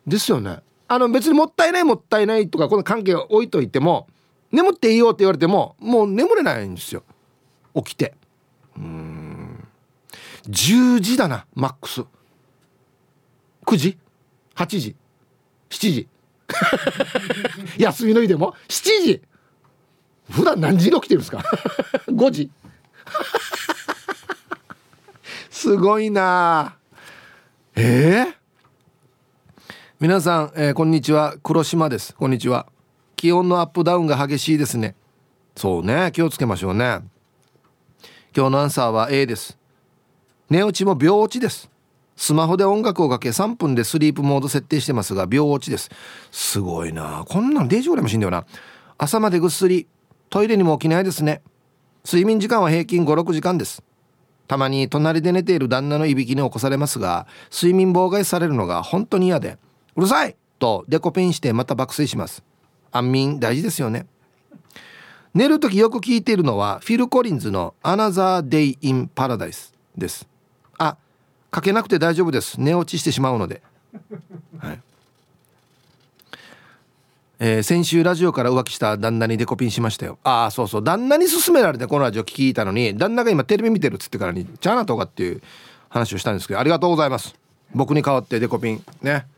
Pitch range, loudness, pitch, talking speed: 130-190 Hz, -19 LUFS, 155 Hz, 320 characters per minute